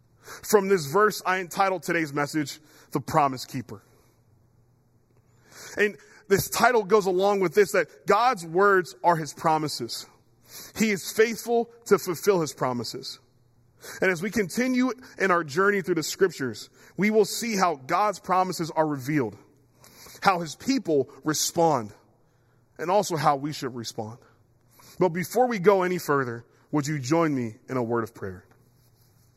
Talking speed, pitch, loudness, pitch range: 150 wpm, 155 Hz, -25 LUFS, 125-195 Hz